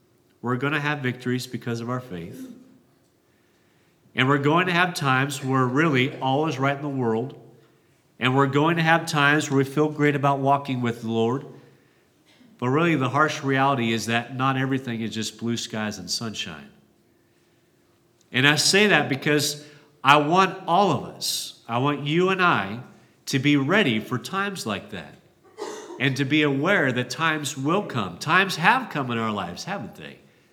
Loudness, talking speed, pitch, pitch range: -22 LUFS, 180 wpm, 140 Hz, 125-155 Hz